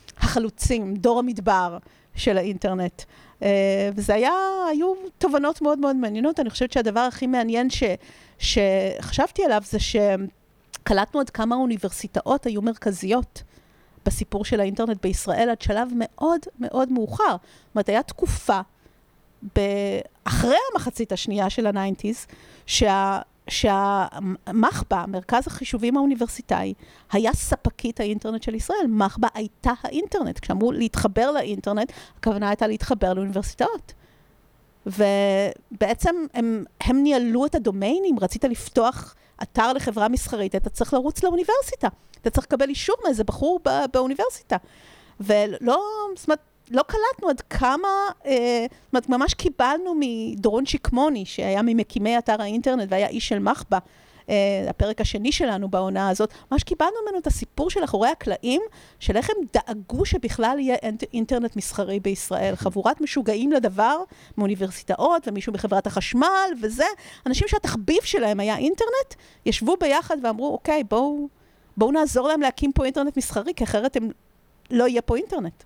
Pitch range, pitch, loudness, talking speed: 210-285 Hz, 235 Hz, -23 LUFS, 130 wpm